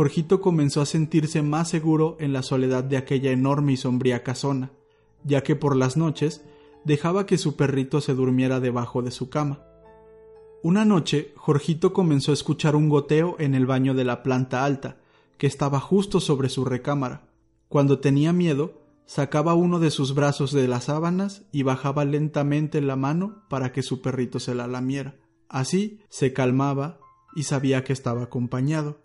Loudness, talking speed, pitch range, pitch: -24 LUFS, 170 wpm, 130-155 Hz, 145 Hz